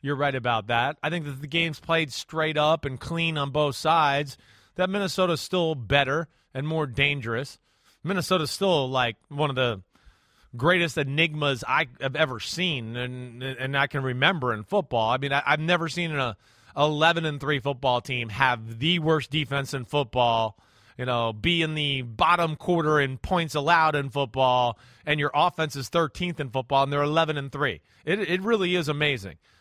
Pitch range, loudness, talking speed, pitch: 130-165 Hz, -25 LUFS, 180 wpm, 145 Hz